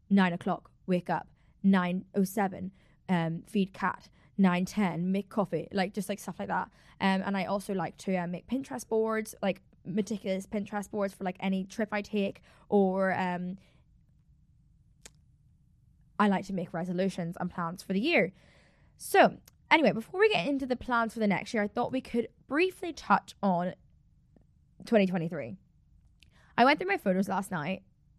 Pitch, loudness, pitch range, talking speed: 195 Hz, -30 LUFS, 180-210 Hz, 170 wpm